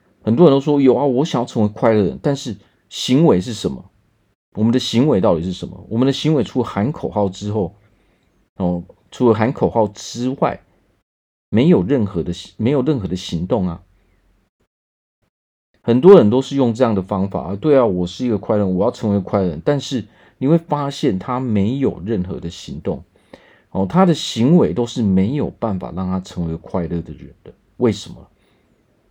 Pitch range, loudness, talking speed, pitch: 95-125 Hz, -18 LUFS, 270 characters per minute, 105 Hz